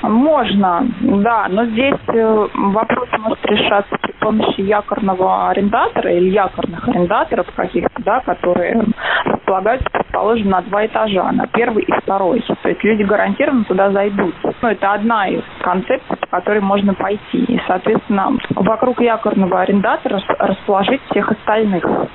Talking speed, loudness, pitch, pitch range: 135 wpm, -15 LUFS, 210 Hz, 195-235 Hz